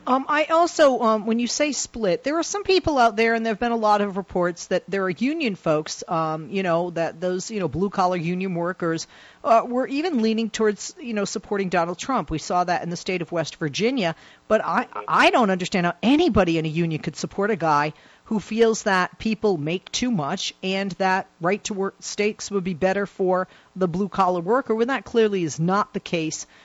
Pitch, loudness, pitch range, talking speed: 195 Hz, -23 LUFS, 175-230 Hz, 225 wpm